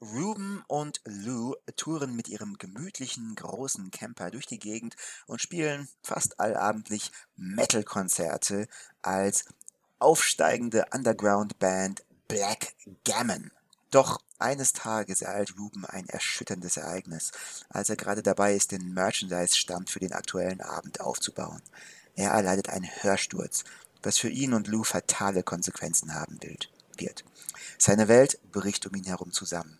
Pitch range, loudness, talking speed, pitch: 95-115 Hz, -28 LUFS, 125 wpm, 105 Hz